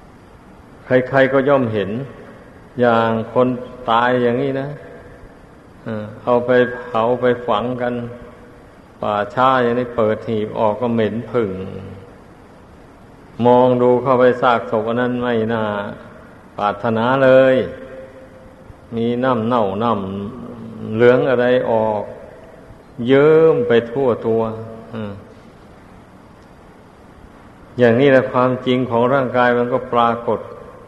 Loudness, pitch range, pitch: -17 LUFS, 110-125 Hz, 120 Hz